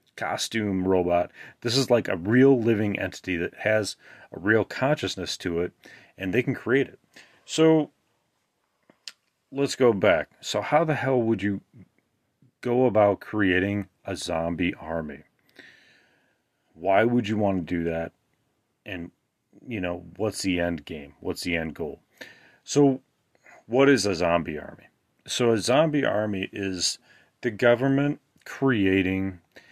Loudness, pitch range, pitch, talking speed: -25 LUFS, 90-120 Hz, 100 Hz, 140 wpm